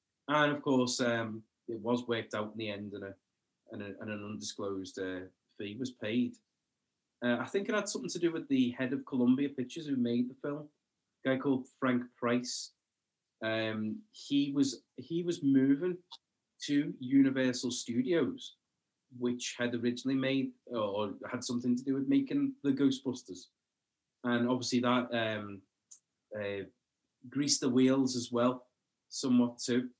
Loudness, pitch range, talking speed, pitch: -33 LUFS, 120-135 Hz, 160 wpm, 125 Hz